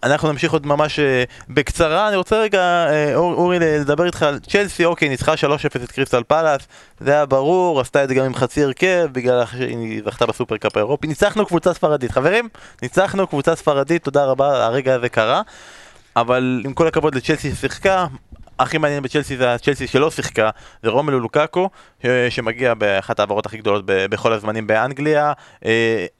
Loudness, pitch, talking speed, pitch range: -18 LUFS, 145 Hz, 165 wpm, 125-160 Hz